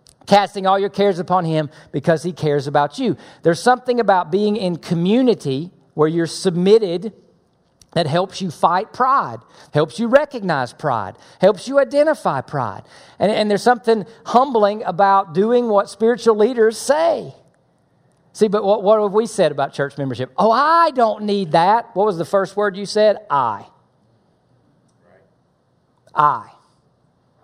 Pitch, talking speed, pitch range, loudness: 195 Hz, 150 wpm, 165-225 Hz, -17 LUFS